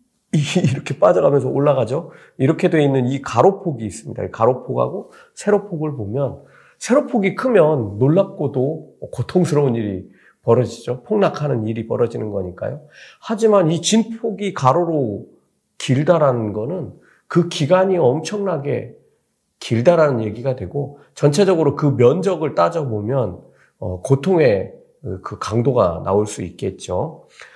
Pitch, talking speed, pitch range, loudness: 145 Hz, 285 characters per minute, 120-180 Hz, -18 LUFS